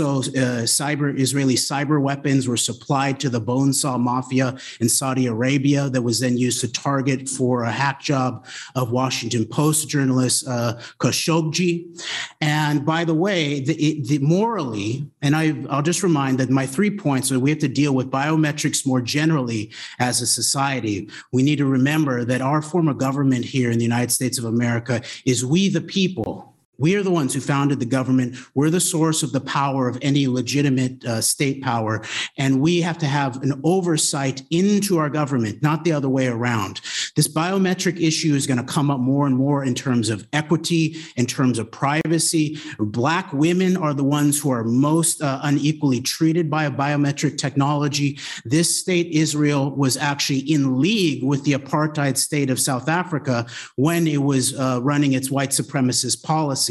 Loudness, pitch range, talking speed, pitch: -20 LUFS, 130-155 Hz, 180 wpm, 140 Hz